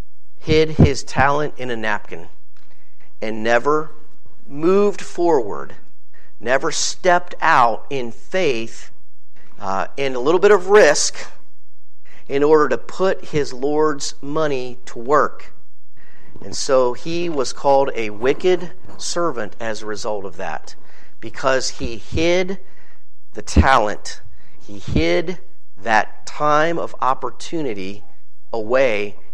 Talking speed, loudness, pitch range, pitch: 115 wpm, -19 LUFS, 115-170 Hz, 145 Hz